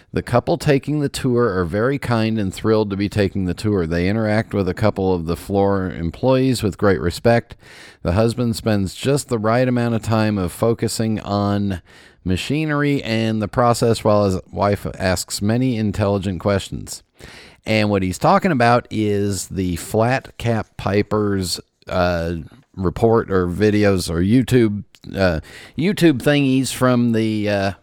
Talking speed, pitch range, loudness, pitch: 155 wpm, 95-120 Hz, -19 LUFS, 105 Hz